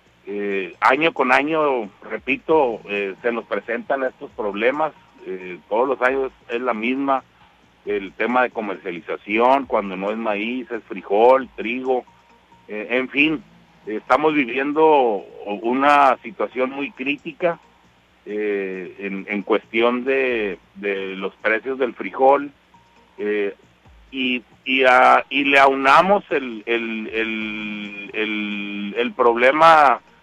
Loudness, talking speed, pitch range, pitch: -19 LUFS, 125 wpm, 105-135 Hz, 120 Hz